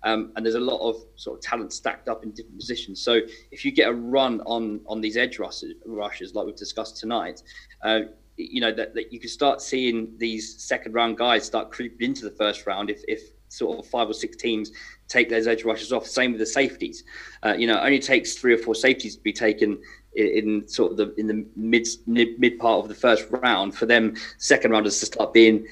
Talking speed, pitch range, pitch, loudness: 235 wpm, 110-135 Hz, 115 Hz, -23 LUFS